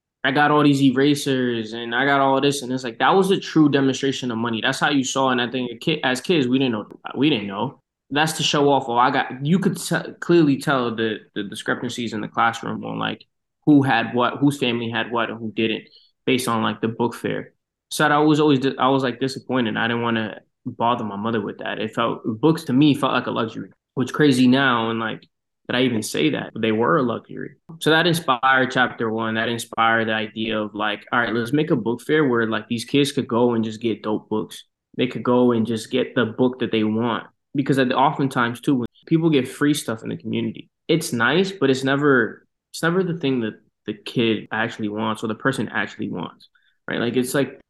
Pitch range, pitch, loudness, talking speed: 115-140 Hz, 125 Hz, -21 LUFS, 240 wpm